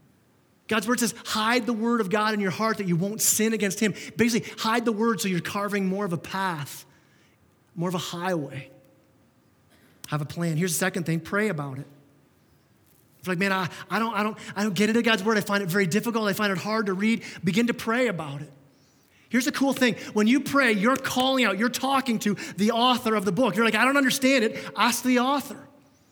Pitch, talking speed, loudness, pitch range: 215 Hz, 230 wpm, -24 LUFS, 185-235 Hz